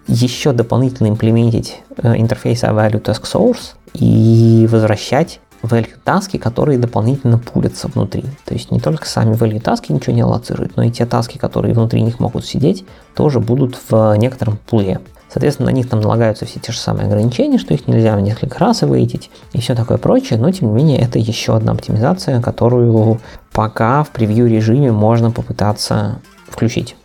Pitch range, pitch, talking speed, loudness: 110-125 Hz, 115 Hz, 170 wpm, -14 LUFS